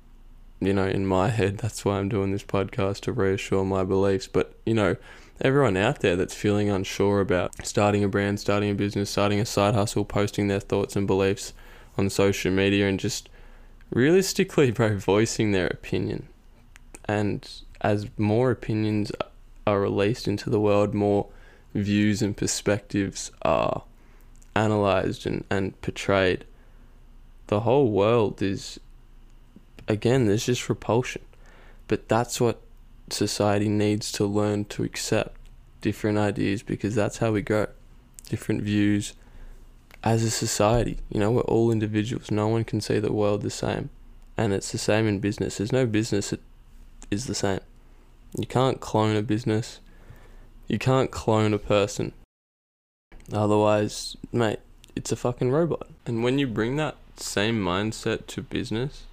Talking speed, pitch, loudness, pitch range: 150 wpm, 105 Hz, -25 LUFS, 100-115 Hz